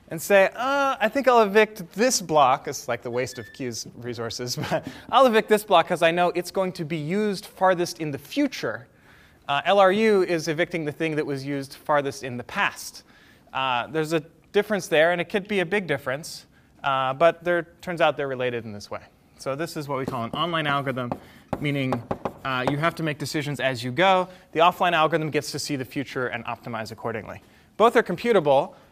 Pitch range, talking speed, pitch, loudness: 135-185 Hz, 210 wpm, 160 Hz, -24 LUFS